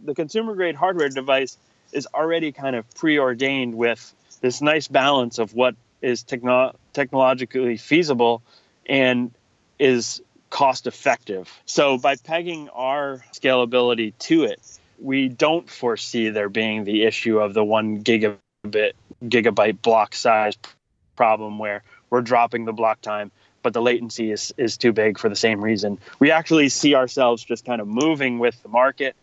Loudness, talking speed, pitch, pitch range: -21 LUFS, 150 wpm, 120 Hz, 110-135 Hz